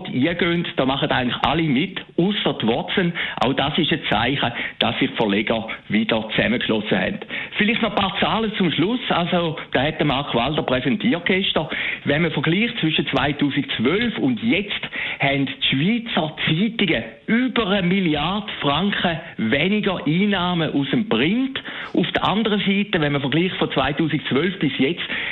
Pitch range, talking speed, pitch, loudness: 140-200 Hz, 150 wpm, 170 Hz, -20 LUFS